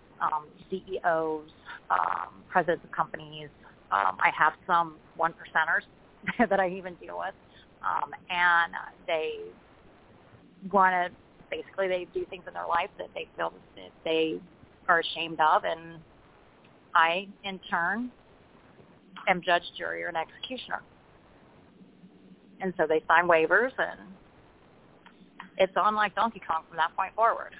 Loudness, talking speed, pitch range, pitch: -28 LUFS, 135 wpm, 165-195 Hz, 180 Hz